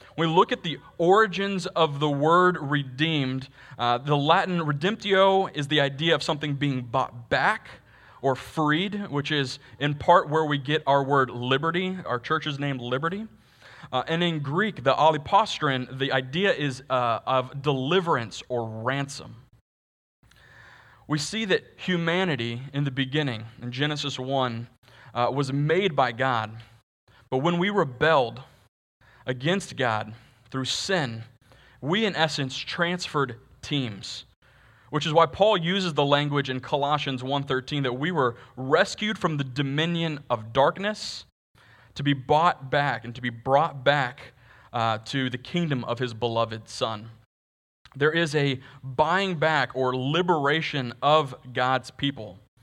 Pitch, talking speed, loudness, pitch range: 140 Hz, 145 wpm, -25 LUFS, 125-160 Hz